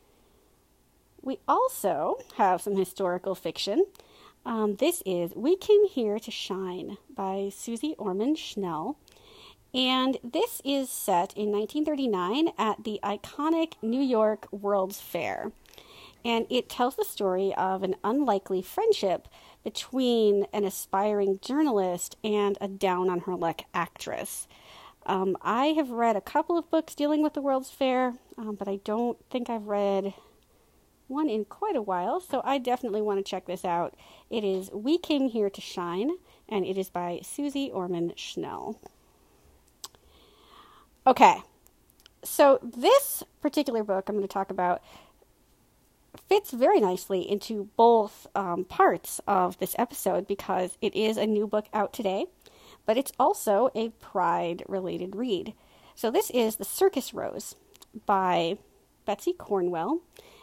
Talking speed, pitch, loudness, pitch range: 140 wpm, 215 Hz, -28 LUFS, 195-280 Hz